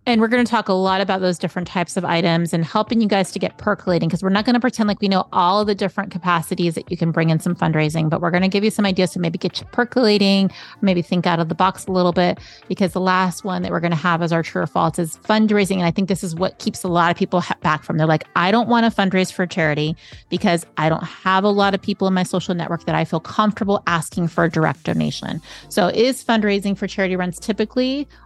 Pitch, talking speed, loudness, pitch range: 185 Hz, 275 wpm, -19 LUFS, 170-200 Hz